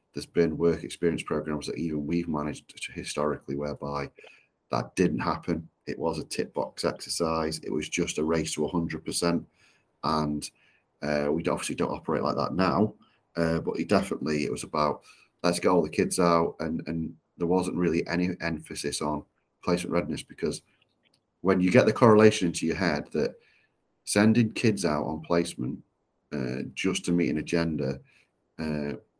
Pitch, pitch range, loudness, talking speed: 80 Hz, 75-85 Hz, -28 LUFS, 170 wpm